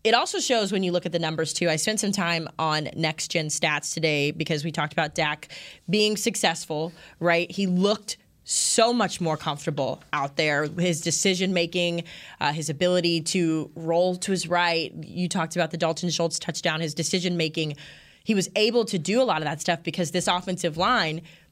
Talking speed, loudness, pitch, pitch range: 195 wpm, -25 LUFS, 170 Hz, 160-185 Hz